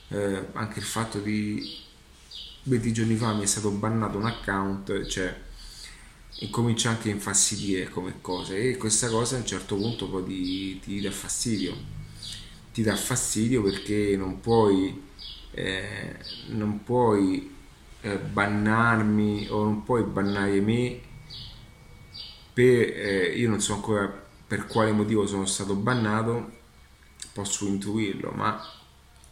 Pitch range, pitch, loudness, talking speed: 95-115 Hz, 105 Hz, -26 LUFS, 130 wpm